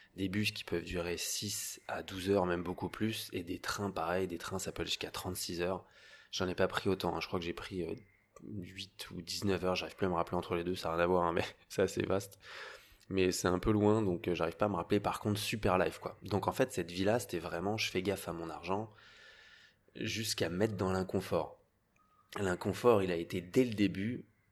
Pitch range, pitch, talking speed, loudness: 90-105 Hz, 95 Hz, 240 wpm, -35 LUFS